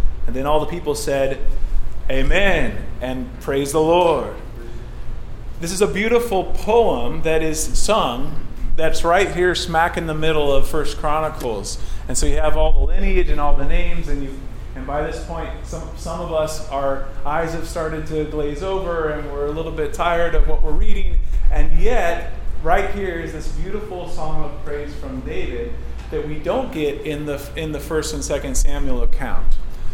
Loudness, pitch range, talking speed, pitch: -22 LUFS, 140-165 Hz, 185 wpm, 155 Hz